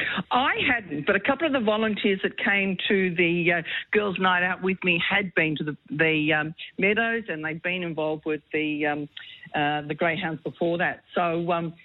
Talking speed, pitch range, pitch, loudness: 210 wpm, 155-195 Hz, 175 Hz, -24 LUFS